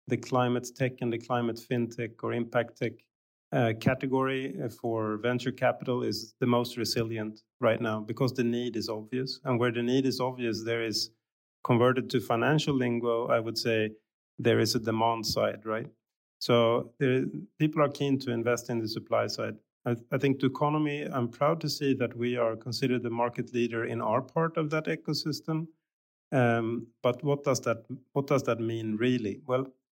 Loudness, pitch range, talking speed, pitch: -30 LUFS, 115-130 Hz, 185 wpm, 120 Hz